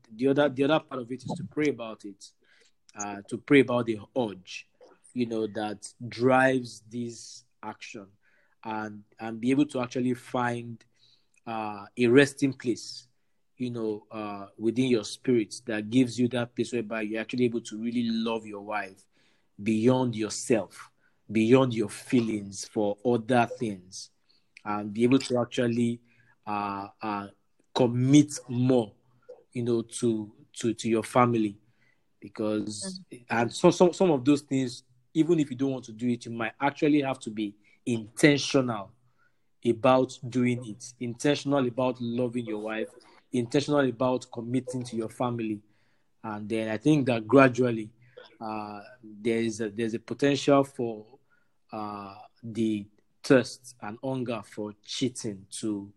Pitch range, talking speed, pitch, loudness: 110-130 Hz, 150 wpm, 120 Hz, -28 LUFS